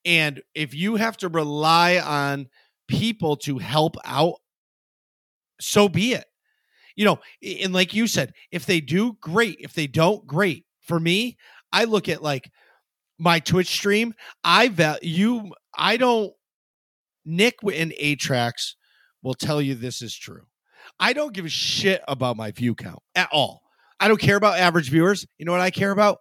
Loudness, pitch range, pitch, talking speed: -22 LUFS, 150-205 Hz, 175 Hz, 170 wpm